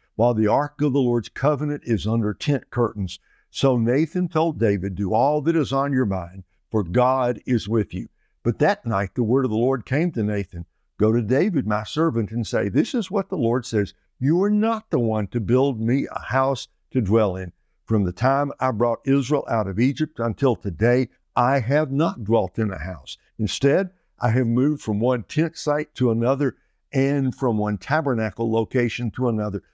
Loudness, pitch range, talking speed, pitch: -22 LUFS, 110-140 Hz, 200 wpm, 120 Hz